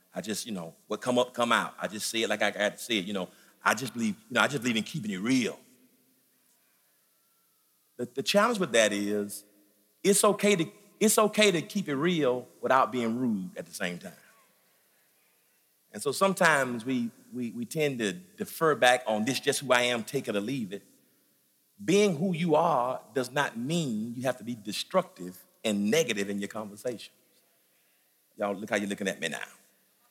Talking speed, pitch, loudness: 200 wpm, 130 Hz, -28 LUFS